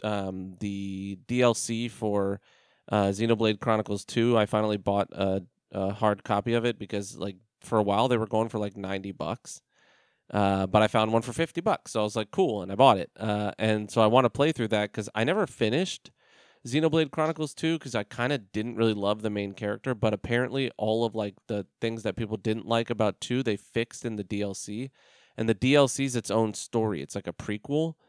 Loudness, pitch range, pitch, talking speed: -28 LUFS, 100-120 Hz, 110 Hz, 215 wpm